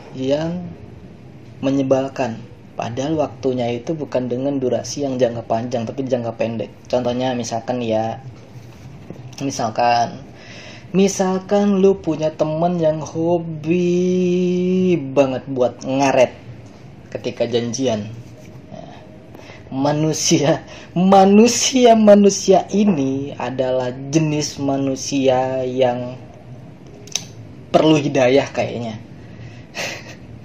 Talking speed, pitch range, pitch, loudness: 80 wpm, 125-160 Hz, 135 Hz, -18 LUFS